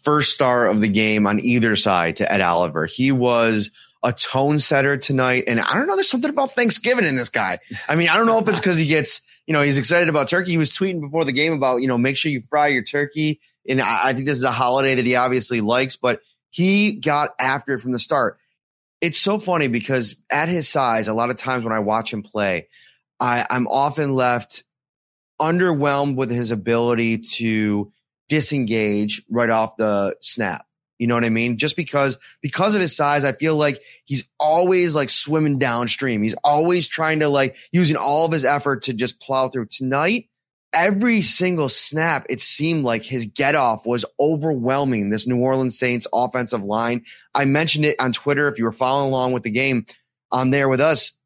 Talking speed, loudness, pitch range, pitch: 205 wpm, -19 LUFS, 120-155 Hz, 135 Hz